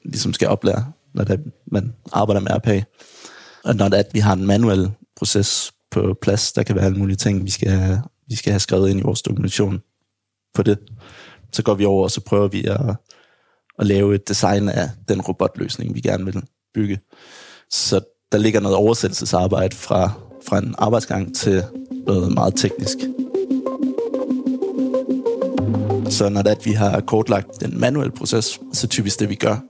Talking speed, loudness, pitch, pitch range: 180 wpm, -20 LUFS, 105 Hz, 100-120 Hz